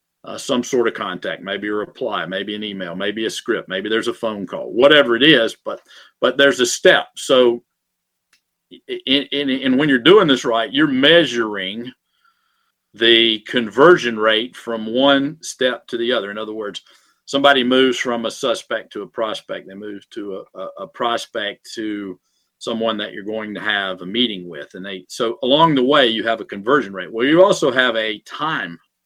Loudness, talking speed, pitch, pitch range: -17 LUFS, 190 wpm, 115 Hz, 105-135 Hz